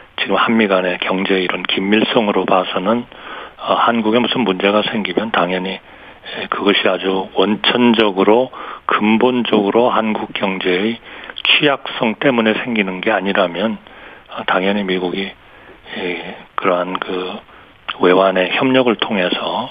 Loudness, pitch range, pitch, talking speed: -16 LUFS, 95-115 Hz, 100 Hz, 270 characters per minute